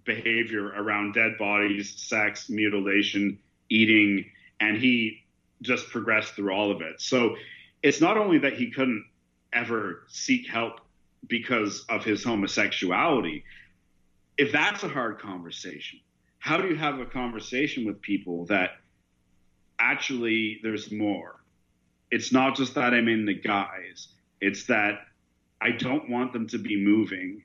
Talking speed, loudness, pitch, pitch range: 140 wpm, -26 LUFS, 105 Hz, 100-120 Hz